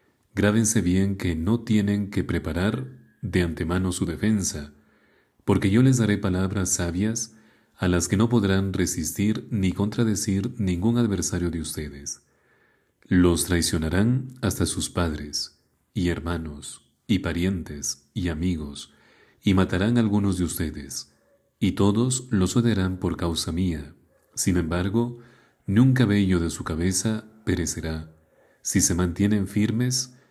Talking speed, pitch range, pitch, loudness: 130 wpm, 85-110 Hz, 95 Hz, -24 LUFS